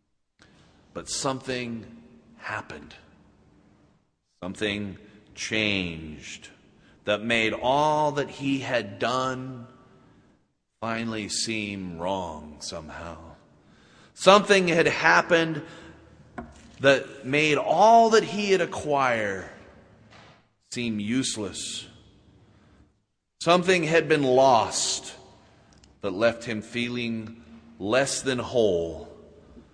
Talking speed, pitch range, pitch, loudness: 80 wpm, 105-140 Hz, 115 Hz, -24 LUFS